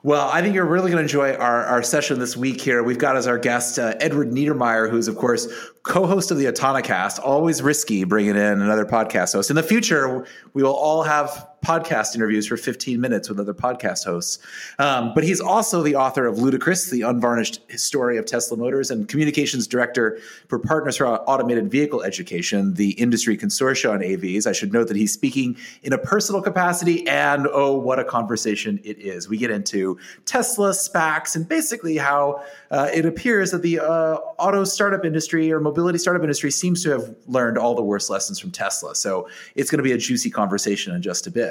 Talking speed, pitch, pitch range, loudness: 205 wpm, 140 Hz, 120-170 Hz, -21 LUFS